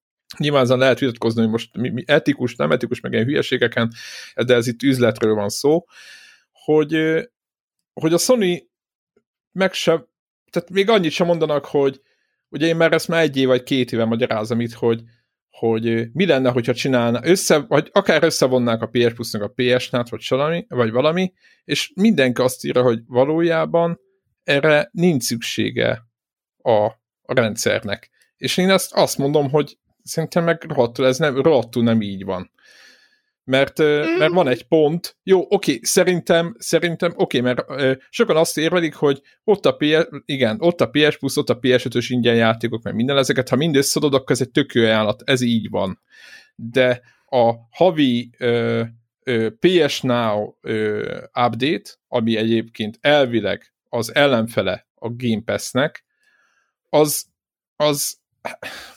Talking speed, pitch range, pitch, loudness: 155 wpm, 120-160 Hz, 130 Hz, -19 LUFS